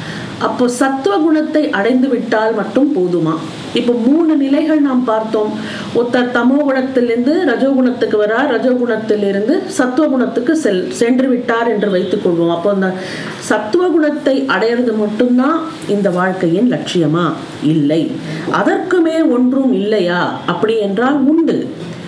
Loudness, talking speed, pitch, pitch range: -14 LUFS, 90 wpm, 240 Hz, 205-275 Hz